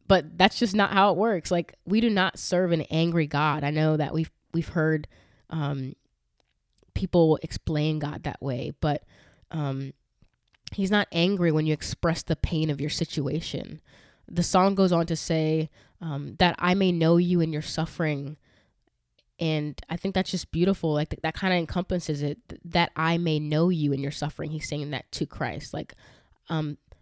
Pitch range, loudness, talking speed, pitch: 150-175 Hz, -26 LUFS, 180 wpm, 160 Hz